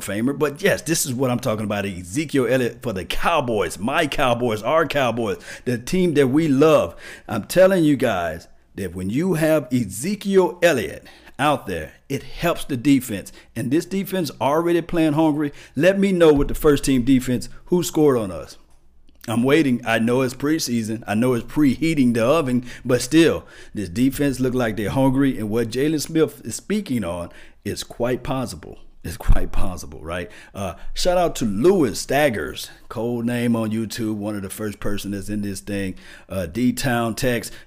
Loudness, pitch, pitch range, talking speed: -21 LUFS, 125 Hz, 110-150 Hz, 180 wpm